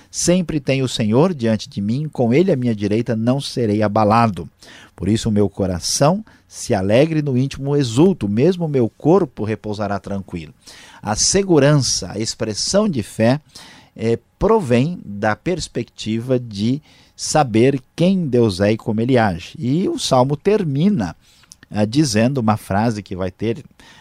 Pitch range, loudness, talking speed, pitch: 105-150 Hz, -18 LUFS, 145 wpm, 120 Hz